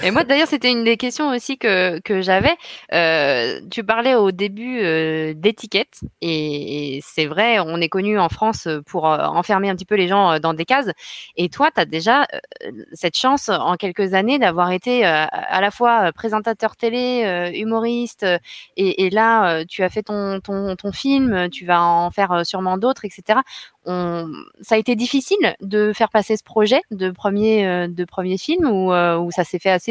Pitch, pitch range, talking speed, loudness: 200 Hz, 180-230 Hz, 205 wpm, -18 LUFS